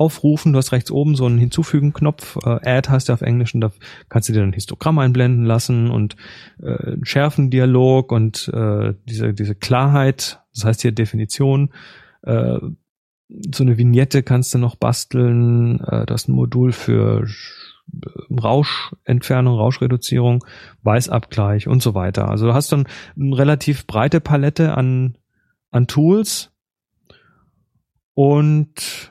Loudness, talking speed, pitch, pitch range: -17 LUFS, 140 wpm, 125 Hz, 115-140 Hz